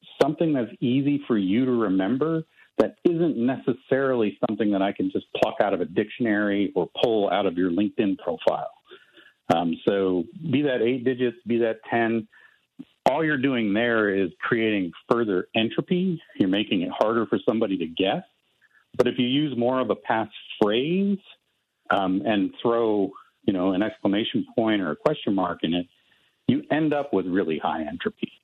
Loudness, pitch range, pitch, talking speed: -24 LUFS, 100-135 Hz, 120 Hz, 175 wpm